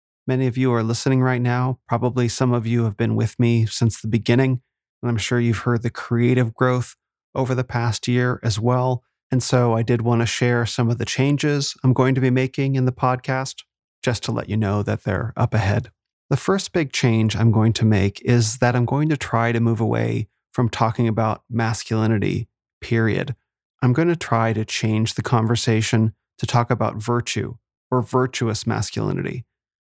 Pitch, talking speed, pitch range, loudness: 120 Hz, 195 wpm, 115-125 Hz, -21 LUFS